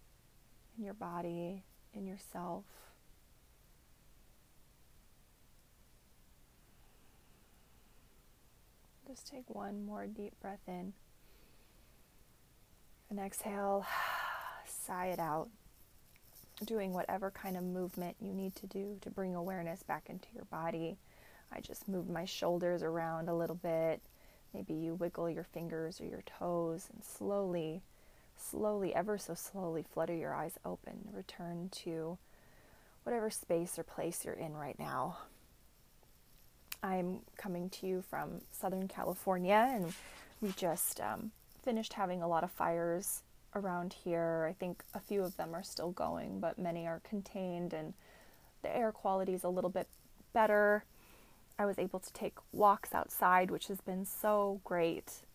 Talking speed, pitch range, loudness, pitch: 135 wpm, 170-200 Hz, -39 LUFS, 185 Hz